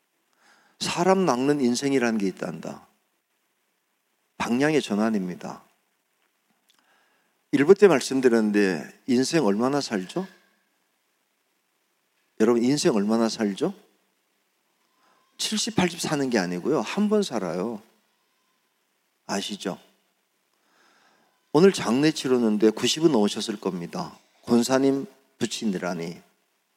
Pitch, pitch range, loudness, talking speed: 130 Hz, 110-180 Hz, -24 LUFS, 190 characters per minute